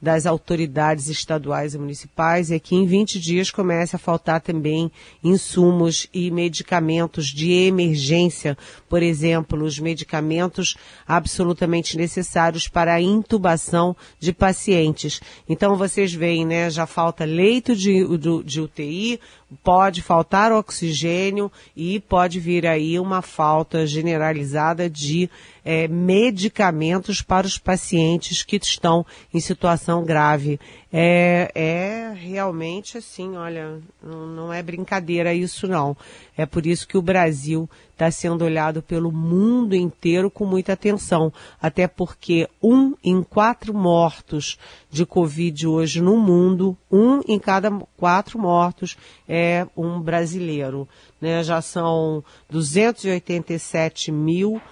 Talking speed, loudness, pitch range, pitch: 120 wpm, -20 LUFS, 160-185 Hz, 170 Hz